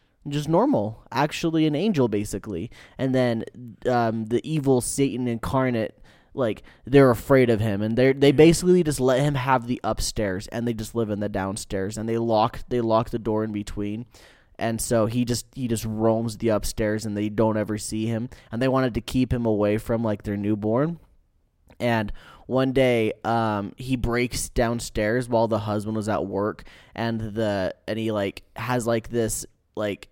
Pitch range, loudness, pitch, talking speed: 105-125 Hz, -24 LUFS, 115 Hz, 185 wpm